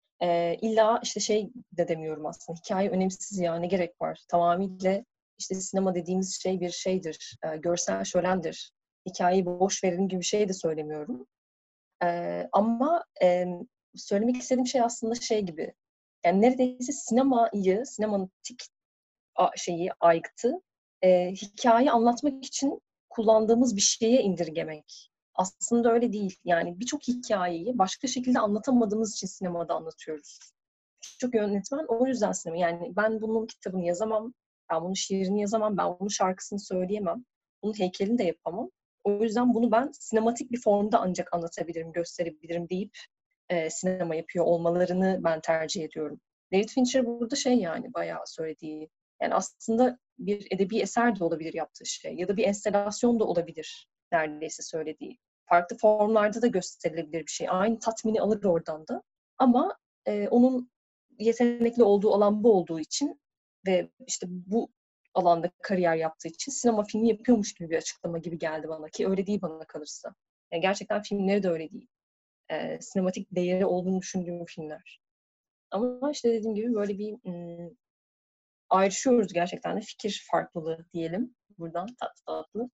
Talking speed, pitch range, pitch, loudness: 145 wpm, 175-230 Hz, 195 Hz, -28 LUFS